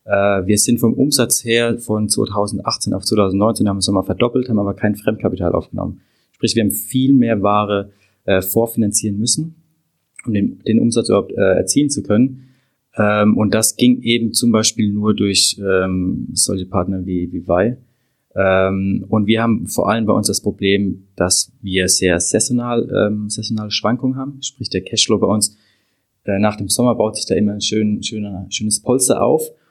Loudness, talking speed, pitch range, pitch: -16 LUFS, 175 wpm, 100-120 Hz, 105 Hz